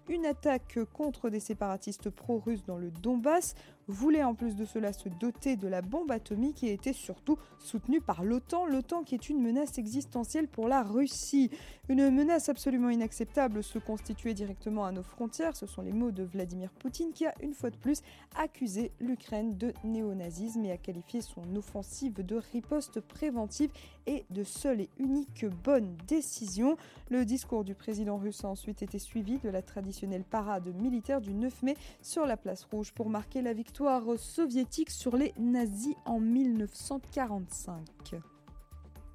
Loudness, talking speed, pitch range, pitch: -34 LUFS, 165 wpm, 205-270 Hz, 235 Hz